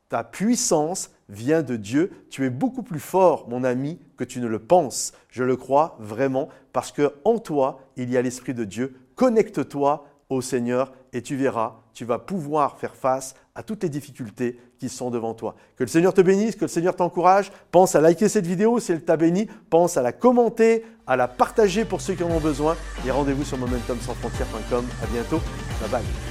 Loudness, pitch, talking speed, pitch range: -23 LUFS, 145 Hz, 205 wpm, 125-180 Hz